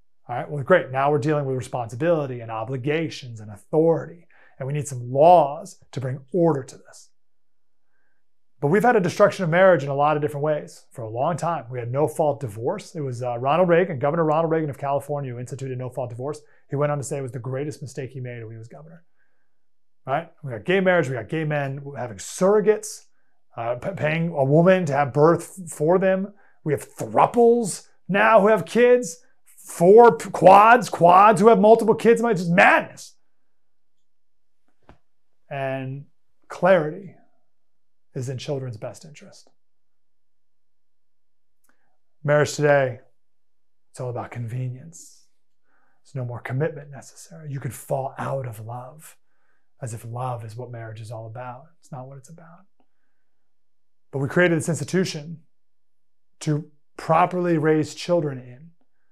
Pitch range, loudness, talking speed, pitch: 120-170 Hz, -21 LUFS, 165 wpm, 140 Hz